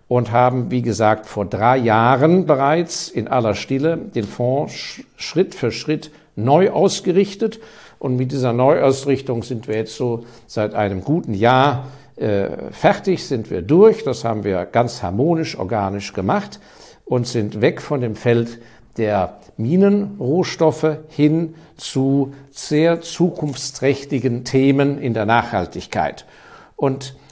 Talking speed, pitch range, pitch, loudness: 130 wpm, 115-155 Hz, 130 Hz, -18 LUFS